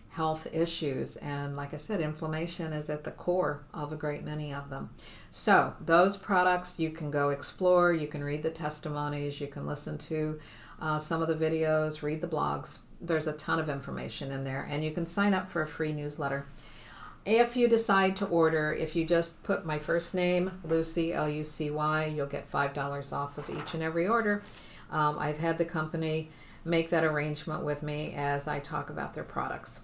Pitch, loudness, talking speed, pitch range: 155 Hz, -31 LUFS, 200 wpm, 150-170 Hz